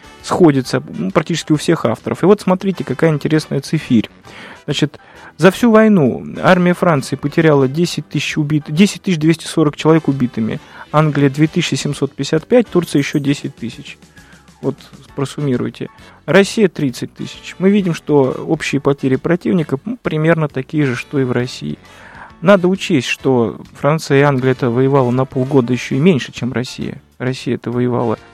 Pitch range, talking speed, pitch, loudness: 130-170 Hz, 145 wpm, 150 Hz, -15 LUFS